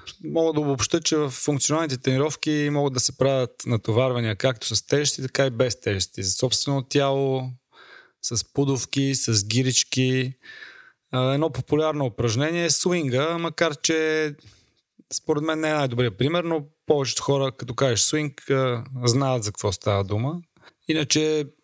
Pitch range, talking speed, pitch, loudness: 125-150 Hz, 140 wpm, 135 Hz, -23 LUFS